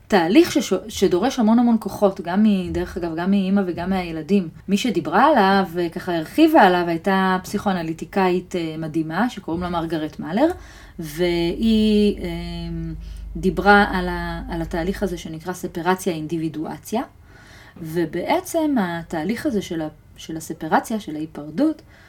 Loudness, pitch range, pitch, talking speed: -21 LUFS, 165-200 Hz, 180 Hz, 125 wpm